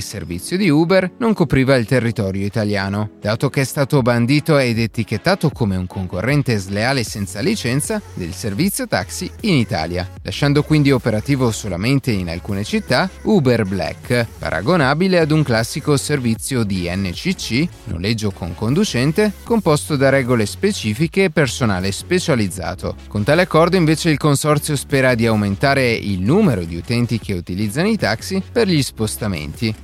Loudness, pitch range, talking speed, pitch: -18 LUFS, 100-150 Hz, 145 wpm, 120 Hz